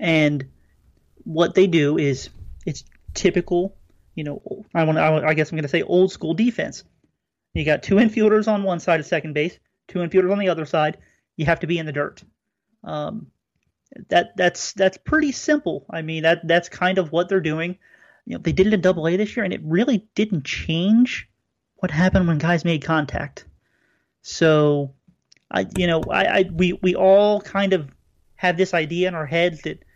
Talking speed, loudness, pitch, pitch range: 195 wpm, -20 LUFS, 175 Hz, 160-190 Hz